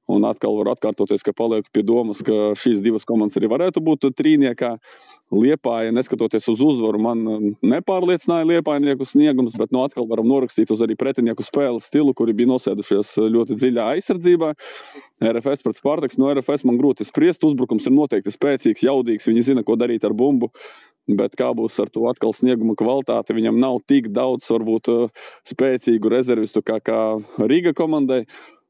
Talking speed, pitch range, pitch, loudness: 165 wpm, 115-140 Hz, 120 Hz, -19 LUFS